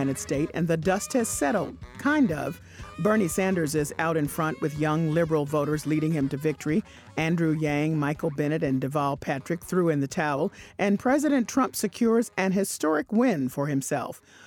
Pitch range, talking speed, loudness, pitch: 145-190 Hz, 175 wpm, -26 LUFS, 155 Hz